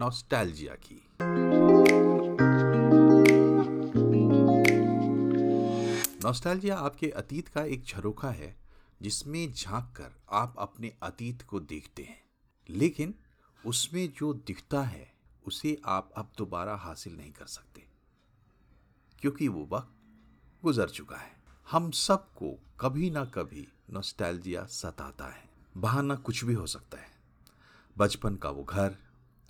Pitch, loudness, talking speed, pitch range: 105 Hz, -27 LUFS, 110 wpm, 85-135 Hz